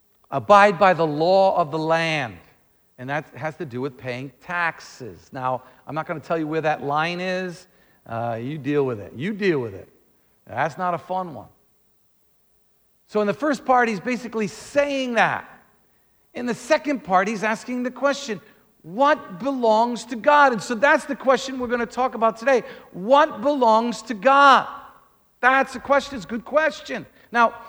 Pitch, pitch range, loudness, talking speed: 220 Hz, 160-255 Hz, -21 LUFS, 180 wpm